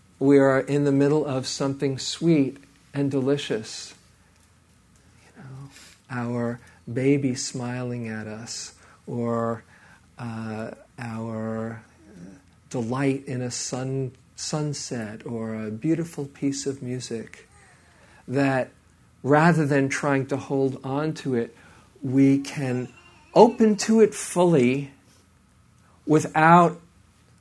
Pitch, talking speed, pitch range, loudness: 130 Hz, 105 wpm, 115-140 Hz, -24 LUFS